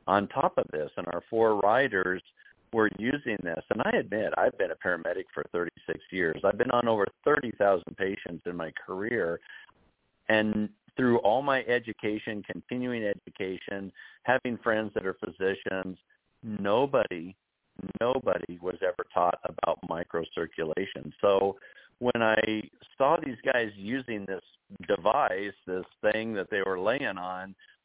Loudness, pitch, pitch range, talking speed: -29 LUFS, 100 Hz, 95-115 Hz, 140 wpm